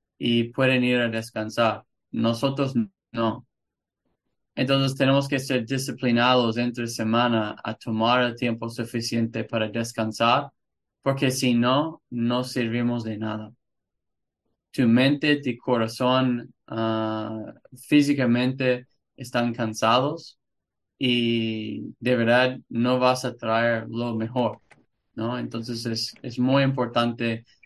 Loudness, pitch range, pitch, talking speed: -24 LUFS, 115-125 Hz, 120 Hz, 110 wpm